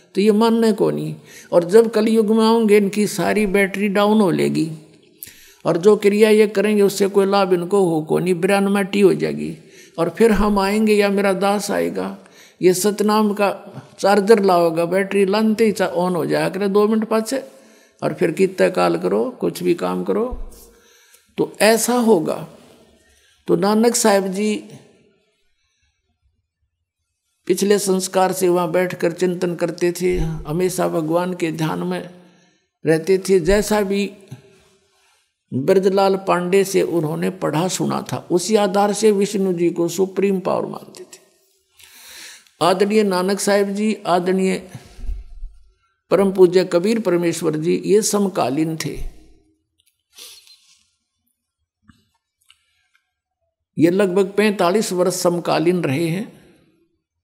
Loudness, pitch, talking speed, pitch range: -18 LUFS, 185 Hz, 130 wpm, 165-205 Hz